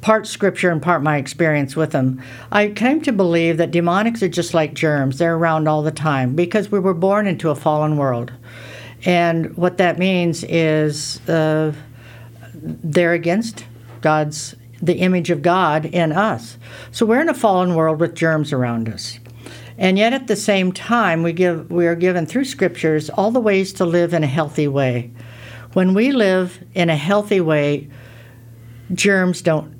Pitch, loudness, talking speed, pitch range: 165 Hz, -18 LUFS, 175 wpm, 135-185 Hz